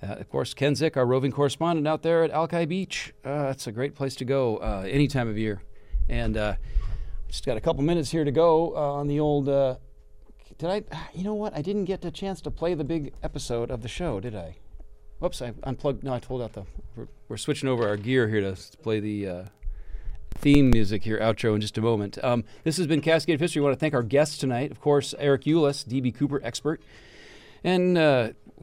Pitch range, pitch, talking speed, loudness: 115-155 Hz, 140 Hz, 230 wpm, -26 LUFS